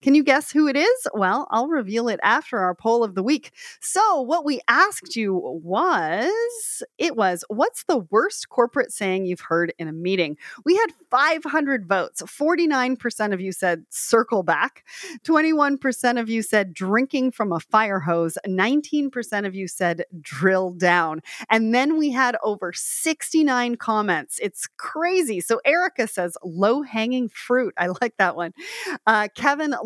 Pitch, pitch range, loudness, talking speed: 235 Hz, 190-300 Hz, -22 LUFS, 160 wpm